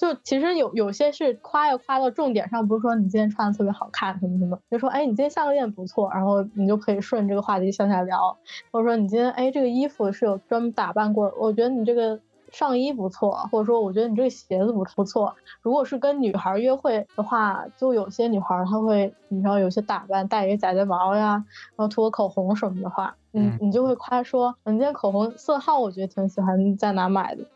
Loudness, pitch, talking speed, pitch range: -23 LUFS, 215 Hz, 350 characters per minute, 200-245 Hz